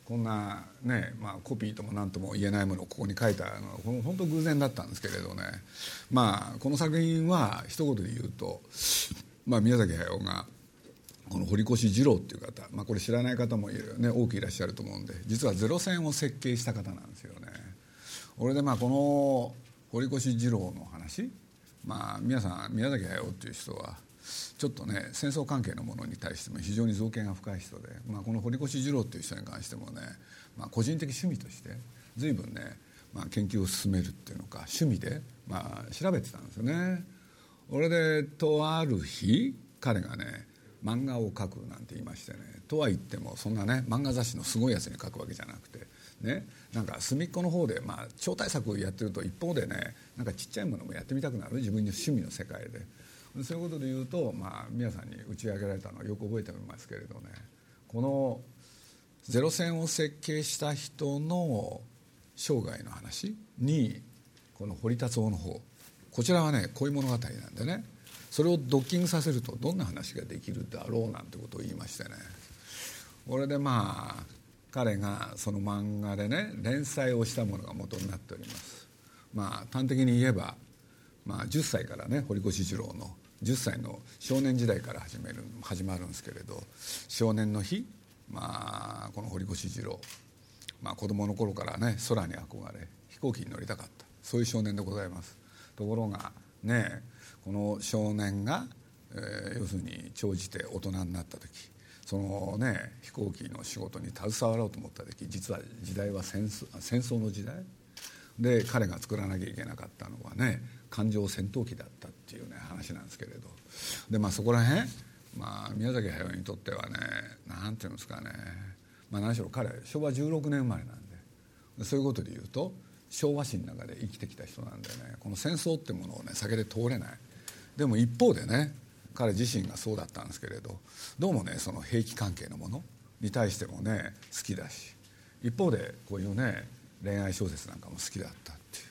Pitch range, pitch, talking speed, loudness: 100-125 Hz, 115 Hz, 345 characters per minute, -33 LUFS